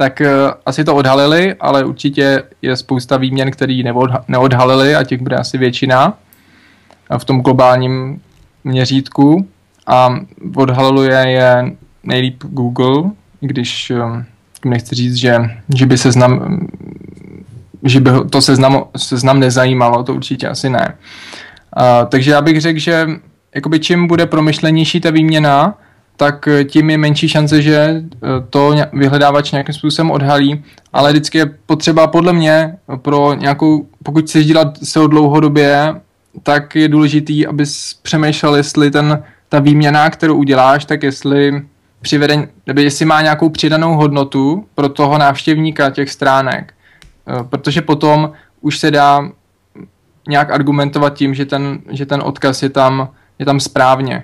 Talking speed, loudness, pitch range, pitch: 135 wpm, -12 LUFS, 130-155 Hz, 145 Hz